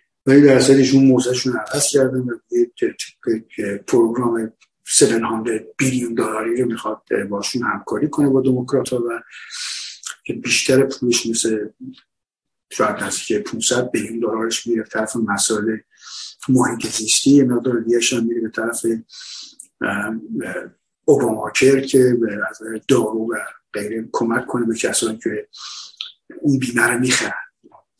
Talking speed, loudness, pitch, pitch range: 125 wpm, -18 LUFS, 120 Hz, 115-130 Hz